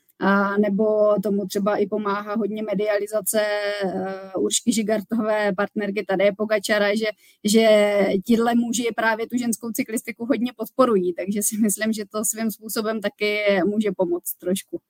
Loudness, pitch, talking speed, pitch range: -22 LUFS, 210 Hz, 140 wpm, 200-220 Hz